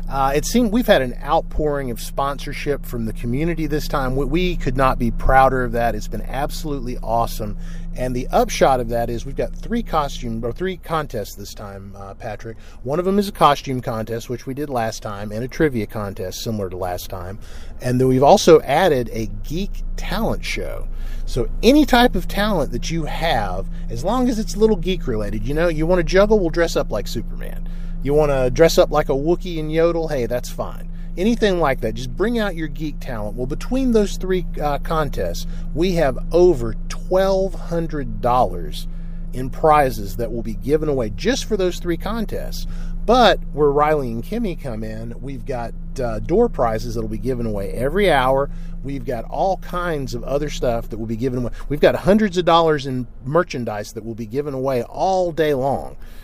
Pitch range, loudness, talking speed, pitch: 115-170 Hz, -20 LUFS, 200 wpm, 140 Hz